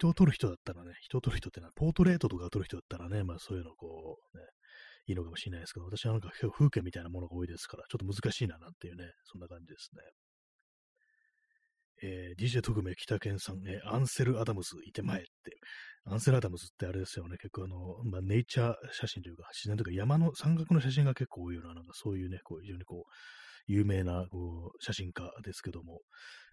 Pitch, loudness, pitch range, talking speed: 100 Hz, -35 LUFS, 90-120 Hz, 470 characters per minute